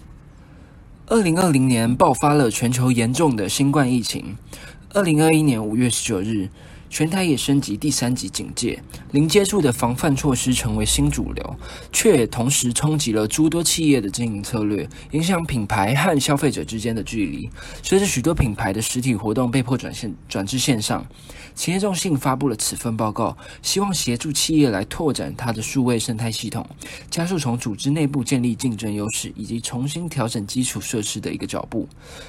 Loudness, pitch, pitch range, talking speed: -21 LUFS, 125 Hz, 115-150 Hz, 285 characters per minute